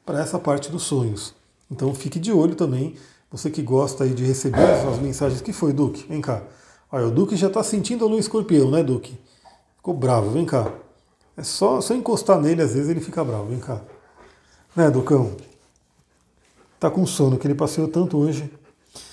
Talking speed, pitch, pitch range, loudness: 190 wpm, 145 Hz, 130-165 Hz, -21 LUFS